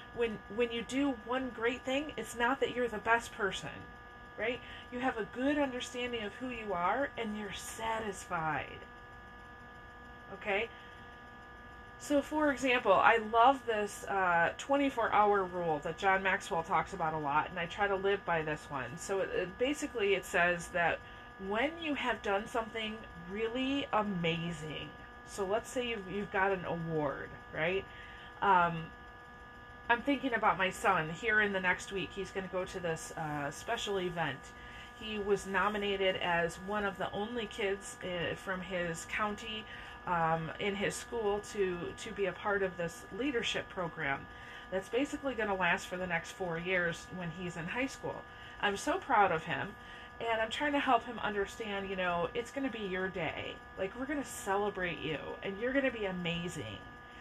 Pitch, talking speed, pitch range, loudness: 195 Hz, 175 wpm, 170-230 Hz, -34 LUFS